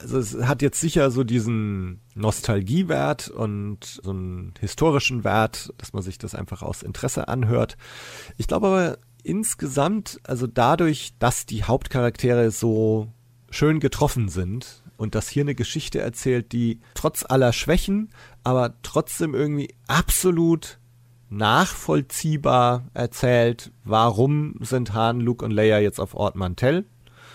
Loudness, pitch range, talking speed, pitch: -23 LUFS, 110-140 Hz, 130 wpm, 120 Hz